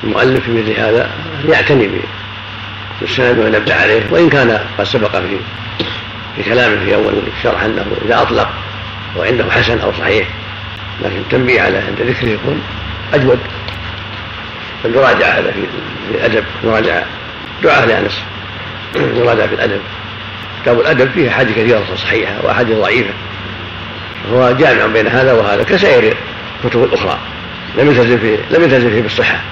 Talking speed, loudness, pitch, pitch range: 125 wpm, -12 LUFS, 105 Hz, 100-110 Hz